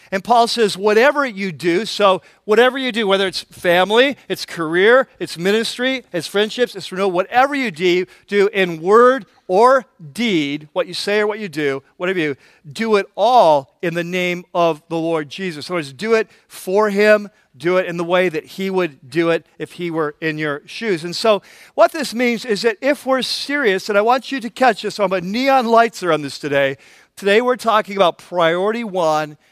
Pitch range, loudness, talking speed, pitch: 170-225 Hz, -17 LUFS, 210 wpm, 195 Hz